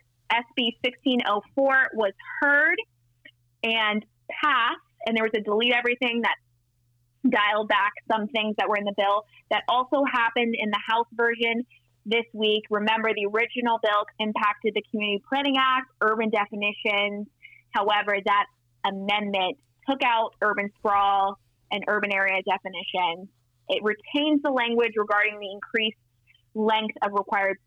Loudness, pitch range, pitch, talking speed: -24 LUFS, 200-230 Hz, 210 Hz, 135 wpm